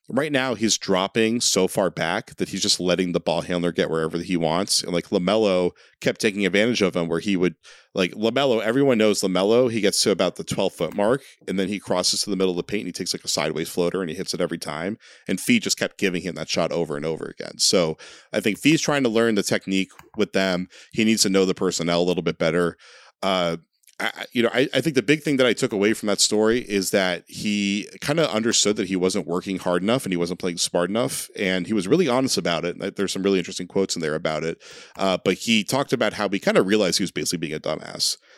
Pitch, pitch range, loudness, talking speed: 95 Hz, 90-110 Hz, -22 LUFS, 260 wpm